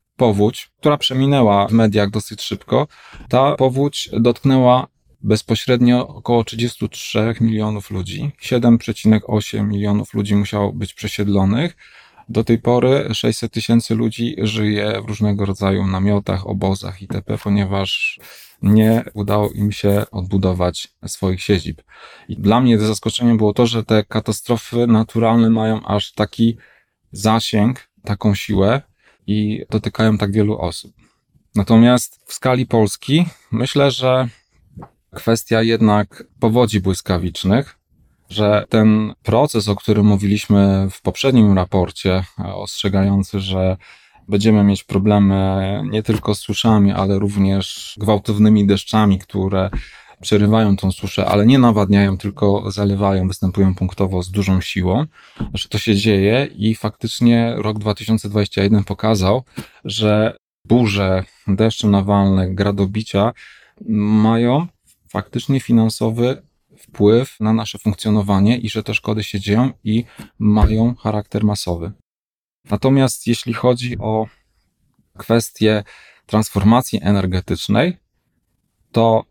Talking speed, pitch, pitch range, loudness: 110 wpm, 105 Hz, 100-115 Hz, -17 LUFS